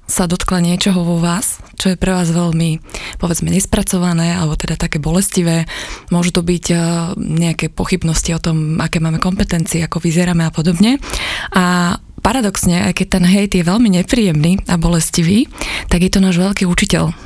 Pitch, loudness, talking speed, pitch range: 175 Hz, -15 LUFS, 165 wpm, 170-185 Hz